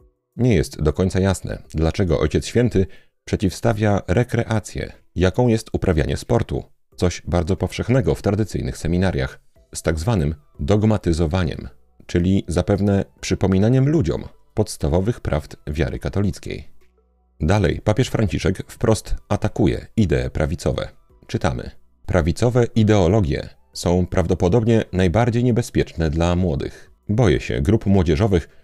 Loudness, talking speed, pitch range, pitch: -20 LUFS, 110 wpm, 80-110 Hz, 95 Hz